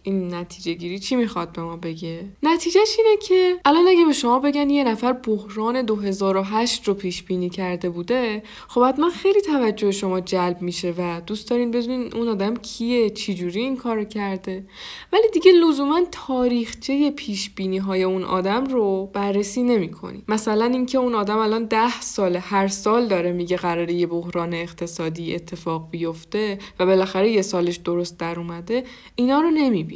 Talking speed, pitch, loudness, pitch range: 170 wpm, 210 Hz, -21 LUFS, 180-250 Hz